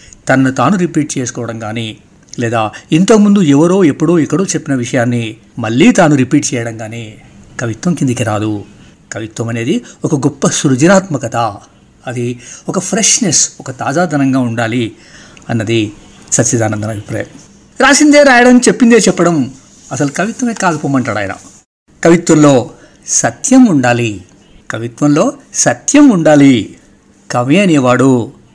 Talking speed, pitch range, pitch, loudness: 105 wpm, 115-175 Hz, 135 Hz, -11 LUFS